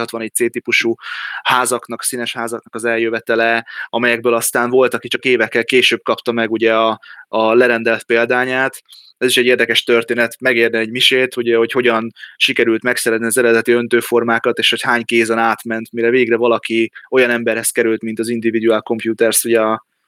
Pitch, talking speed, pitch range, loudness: 115 Hz, 160 wpm, 115-120 Hz, -15 LUFS